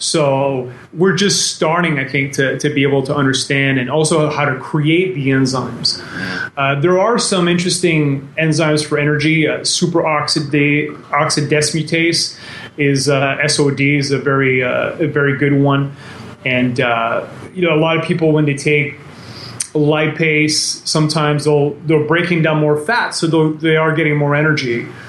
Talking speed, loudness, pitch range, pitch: 155 wpm, -15 LUFS, 140-160 Hz, 150 Hz